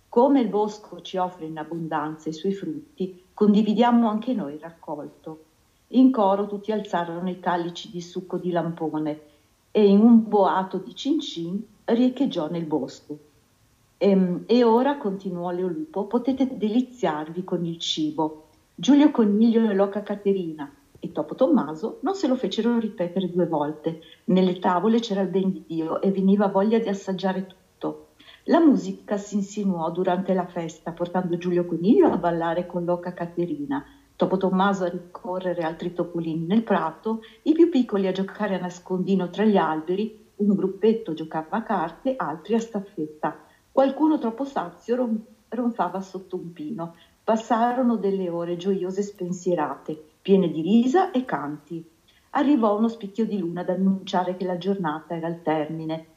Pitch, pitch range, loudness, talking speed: 185 Hz, 170-215 Hz, -24 LUFS, 155 wpm